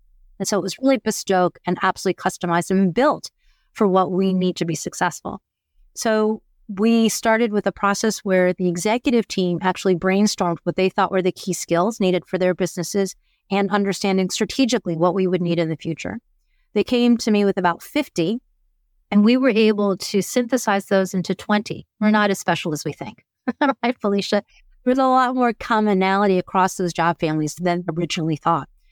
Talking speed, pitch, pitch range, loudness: 185 wpm, 195 Hz, 180-220 Hz, -20 LUFS